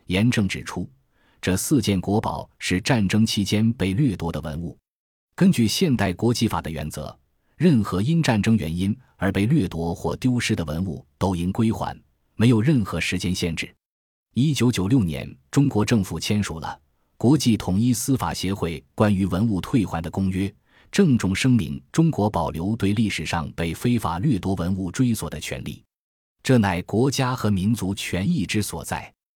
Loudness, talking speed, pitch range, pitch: -23 LUFS, 255 characters per minute, 85-115 Hz, 100 Hz